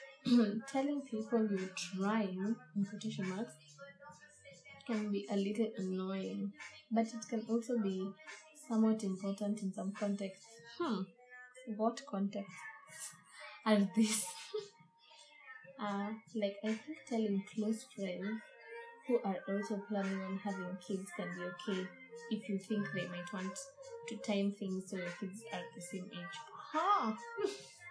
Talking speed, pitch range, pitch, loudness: 130 wpm, 195-235 Hz, 210 Hz, -38 LUFS